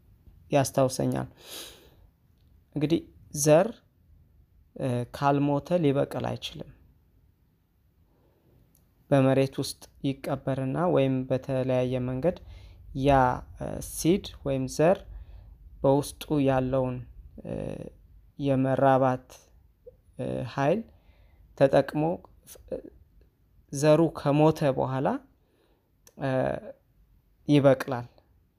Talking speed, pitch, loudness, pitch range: 50 wpm, 130 Hz, -27 LUFS, 90-140 Hz